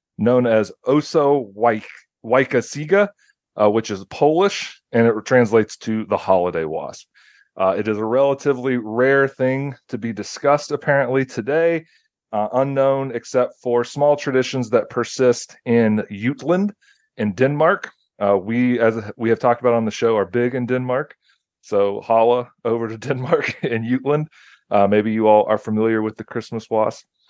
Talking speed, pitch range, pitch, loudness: 160 wpm, 110-135 Hz, 120 Hz, -19 LUFS